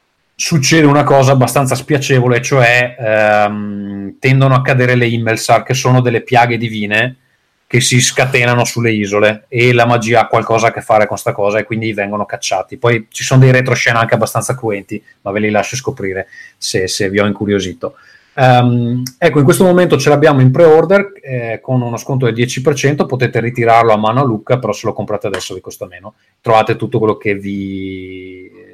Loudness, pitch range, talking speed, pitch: -12 LUFS, 105-130 Hz, 185 wpm, 120 Hz